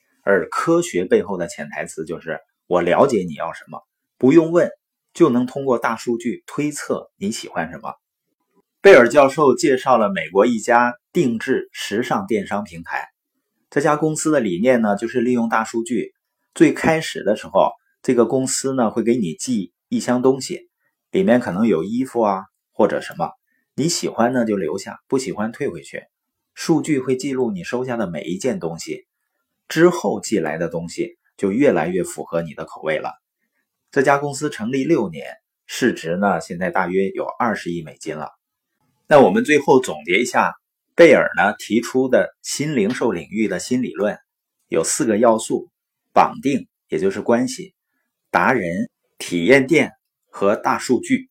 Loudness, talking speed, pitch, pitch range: -19 LUFS, 250 characters per minute, 130 Hz, 115-175 Hz